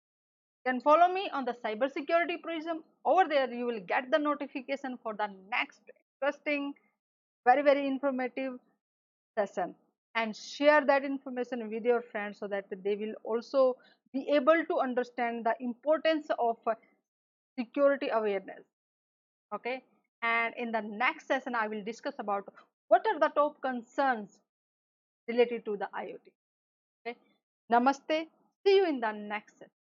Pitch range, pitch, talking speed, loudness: 230-290 Hz, 255 Hz, 145 wpm, -31 LUFS